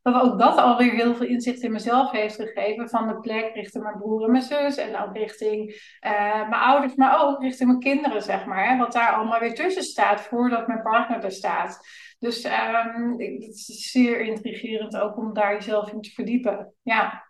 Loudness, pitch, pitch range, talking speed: -23 LUFS, 230 Hz, 215-245 Hz, 210 wpm